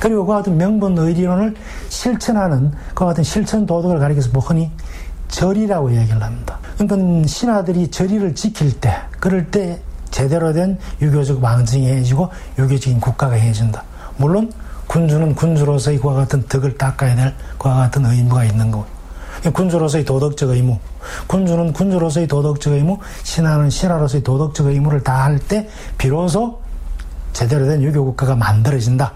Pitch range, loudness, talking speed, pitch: 130-180 Hz, -16 LUFS, 355 characters per minute, 145 Hz